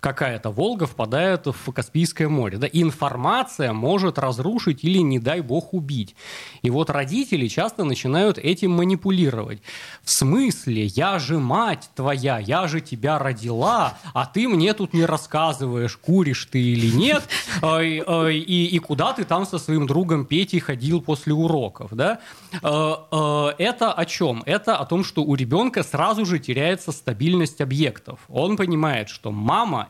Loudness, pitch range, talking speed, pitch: -22 LUFS, 135-175 Hz, 150 wpm, 155 Hz